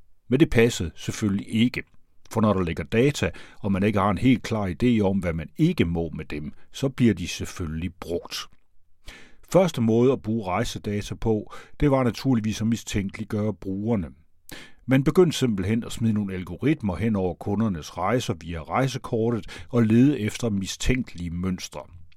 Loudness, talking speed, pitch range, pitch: -25 LUFS, 160 wpm, 90-120 Hz, 105 Hz